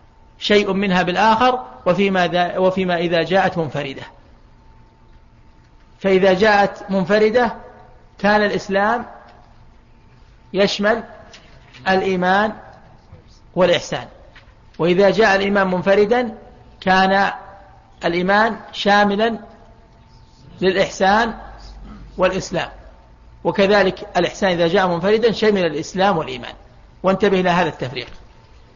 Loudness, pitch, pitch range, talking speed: -17 LUFS, 190 Hz, 165-205 Hz, 75 wpm